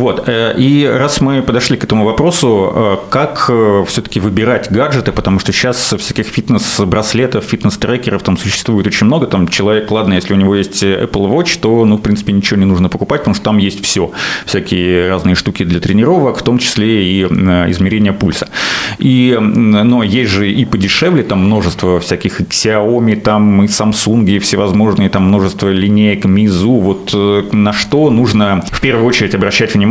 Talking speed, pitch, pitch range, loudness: 170 wpm, 105 Hz, 95-115 Hz, -11 LUFS